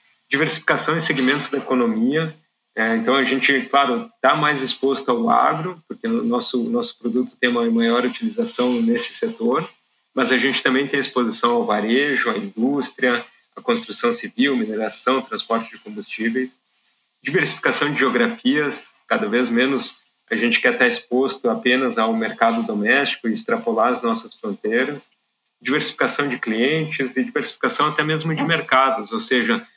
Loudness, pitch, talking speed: -20 LUFS, 140 Hz, 145 wpm